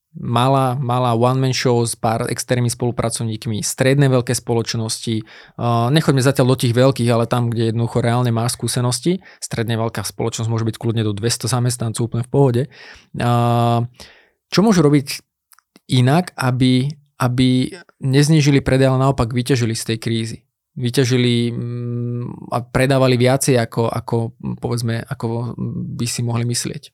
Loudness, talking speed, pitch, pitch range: -18 LUFS, 135 wpm, 120 Hz, 115-130 Hz